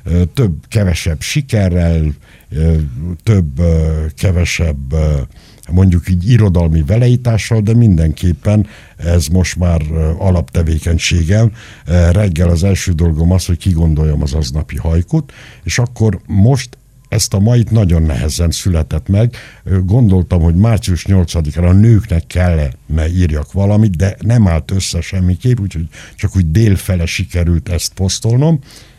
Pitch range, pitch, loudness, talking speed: 85-105 Hz, 90 Hz, -13 LUFS, 120 wpm